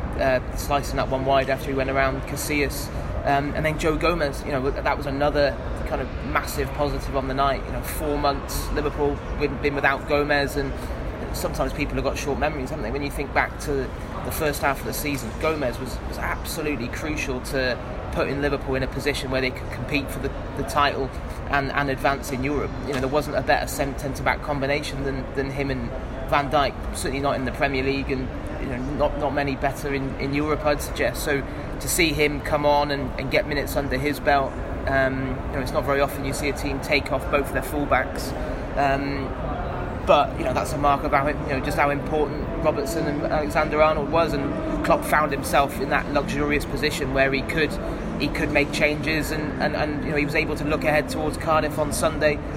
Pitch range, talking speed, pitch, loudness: 135-150 Hz, 215 wpm, 140 Hz, -24 LUFS